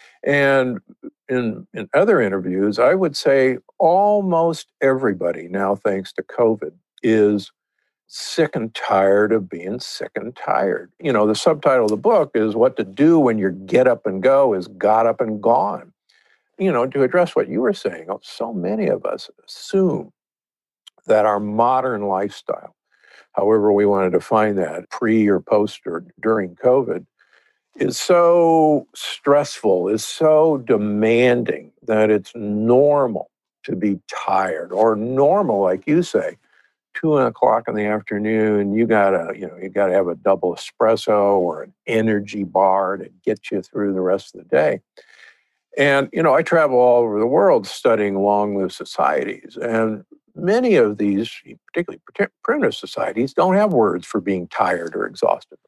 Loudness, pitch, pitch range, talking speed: -18 LUFS, 110 Hz, 100-140 Hz, 155 wpm